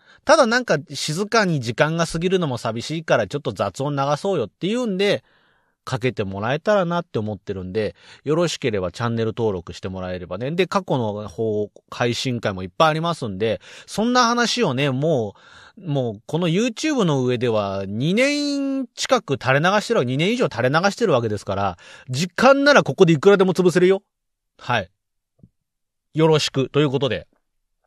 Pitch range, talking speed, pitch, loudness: 120-195 Hz, 370 characters per minute, 150 Hz, -20 LUFS